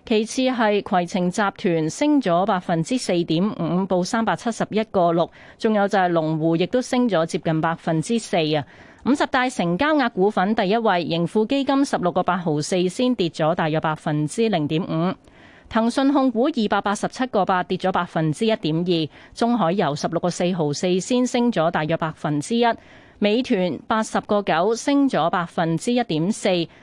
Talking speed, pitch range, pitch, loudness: 275 characters per minute, 170-230 Hz, 185 Hz, -21 LUFS